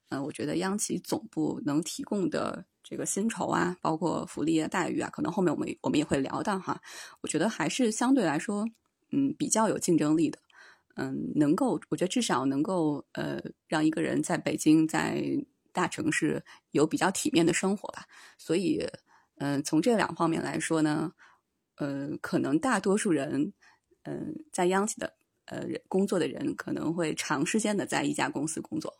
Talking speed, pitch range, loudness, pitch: 270 characters per minute, 155-250 Hz, -29 LUFS, 185 Hz